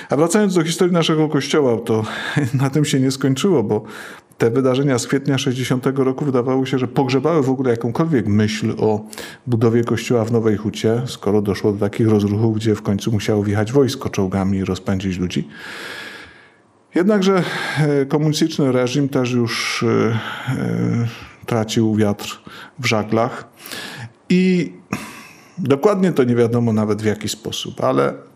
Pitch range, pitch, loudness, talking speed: 105-140 Hz, 120 Hz, -18 LUFS, 140 wpm